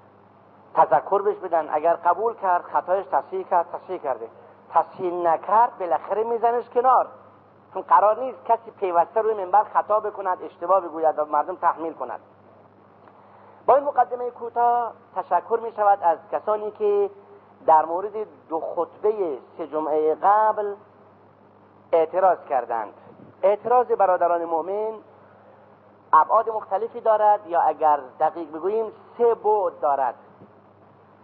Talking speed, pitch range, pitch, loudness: 120 wpm, 160-220 Hz, 185 Hz, -22 LUFS